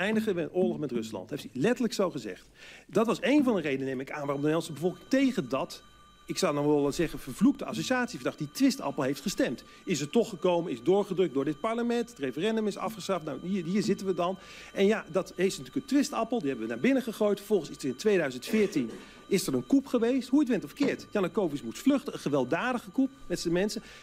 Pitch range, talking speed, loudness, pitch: 160-230 Hz, 230 wpm, -29 LUFS, 190 Hz